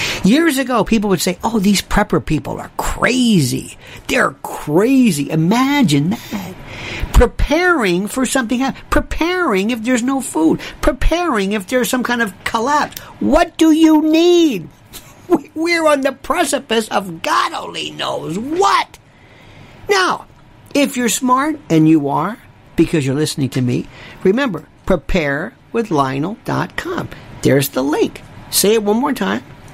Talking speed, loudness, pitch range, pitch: 135 wpm, -16 LUFS, 185-295 Hz, 240 Hz